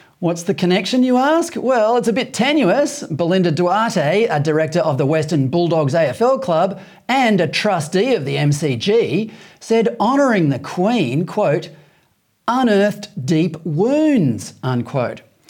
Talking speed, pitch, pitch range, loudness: 135 wpm, 185 Hz, 160-230 Hz, -17 LUFS